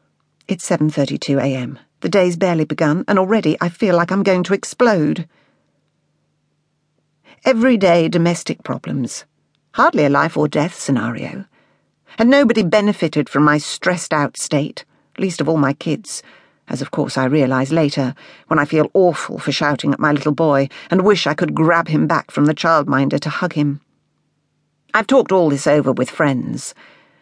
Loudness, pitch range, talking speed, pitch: -17 LUFS, 145-185 Hz, 155 wpm, 155 Hz